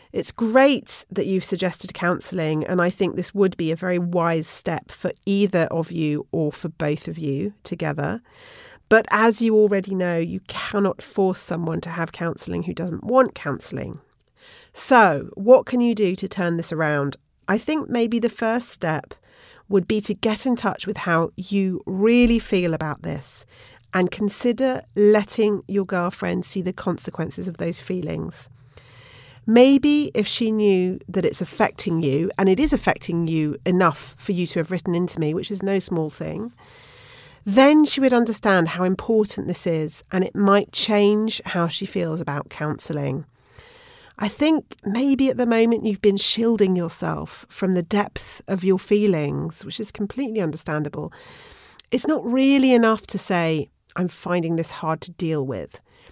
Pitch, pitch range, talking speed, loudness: 190 Hz, 165-220 Hz, 170 wpm, -21 LUFS